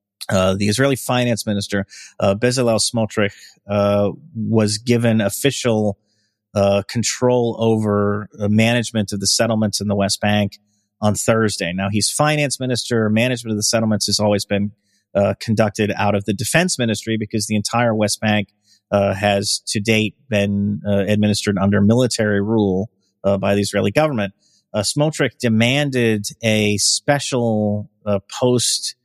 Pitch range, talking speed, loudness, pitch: 100-115 Hz, 145 wpm, -18 LUFS, 105 Hz